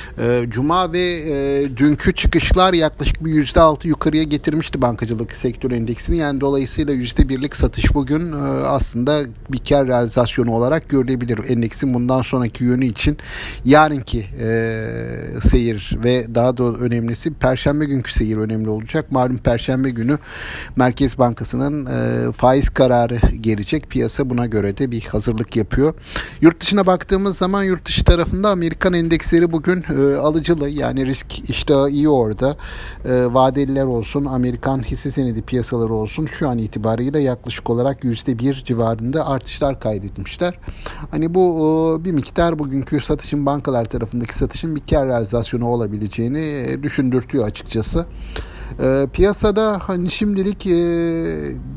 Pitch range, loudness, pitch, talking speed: 120-150 Hz, -18 LUFS, 135 Hz, 120 wpm